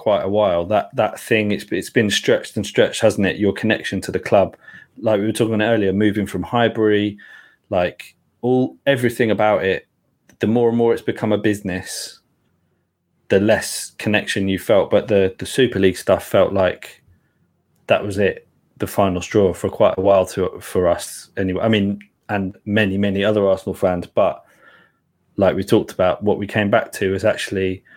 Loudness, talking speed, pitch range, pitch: -19 LUFS, 190 wpm, 95-110 Hz, 105 Hz